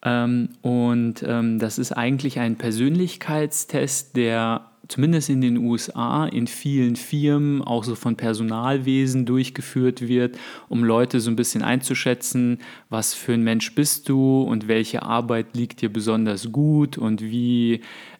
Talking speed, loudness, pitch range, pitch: 140 wpm, -22 LUFS, 115-135 Hz, 120 Hz